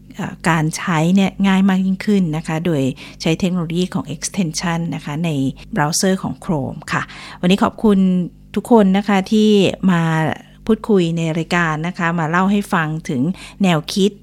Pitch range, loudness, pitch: 165-195 Hz, -17 LUFS, 180 Hz